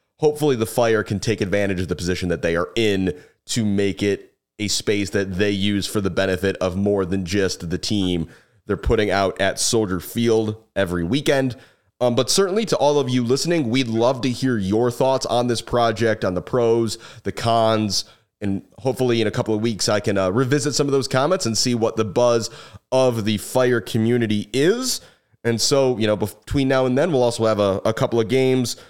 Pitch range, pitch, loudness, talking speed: 100-125 Hz, 115 Hz, -20 LUFS, 210 wpm